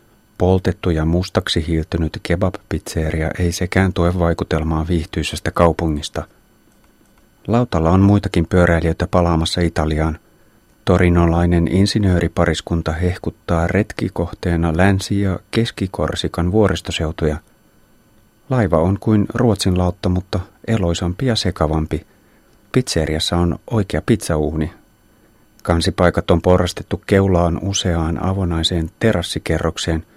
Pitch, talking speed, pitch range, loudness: 90 Hz, 90 wpm, 85-100 Hz, -18 LUFS